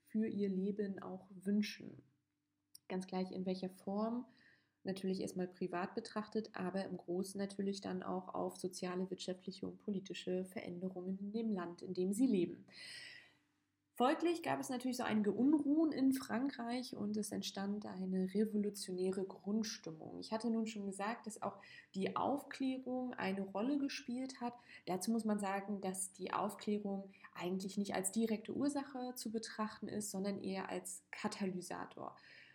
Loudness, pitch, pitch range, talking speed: -41 LUFS, 205 Hz, 185-230 Hz, 145 wpm